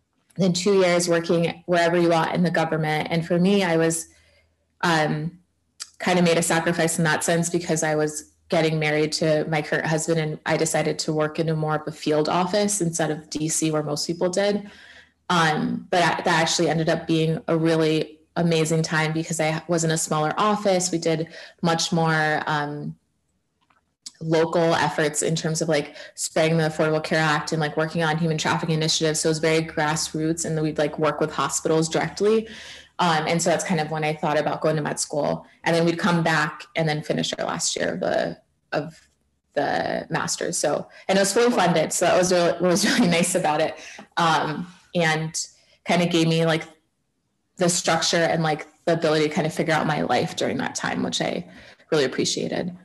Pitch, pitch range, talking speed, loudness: 160 Hz, 155-170 Hz, 200 wpm, -22 LUFS